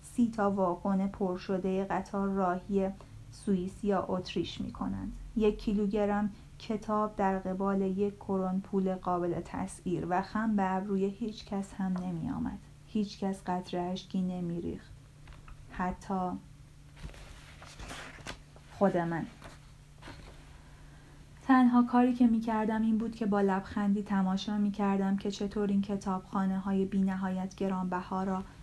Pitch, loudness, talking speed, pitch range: 195 Hz, -32 LUFS, 125 wpm, 185-205 Hz